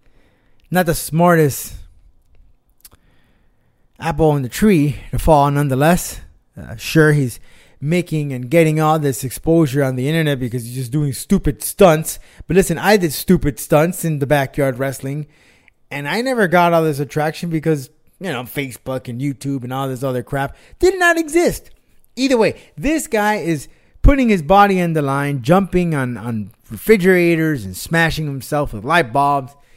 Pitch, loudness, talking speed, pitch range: 150 Hz, -17 LUFS, 160 wpm, 130-170 Hz